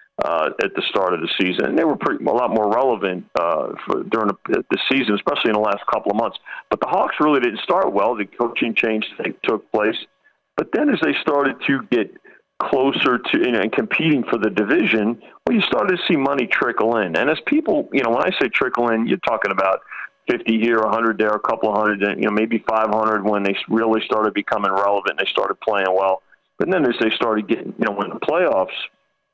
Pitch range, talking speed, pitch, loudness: 105-115 Hz, 235 wpm, 110 Hz, -19 LUFS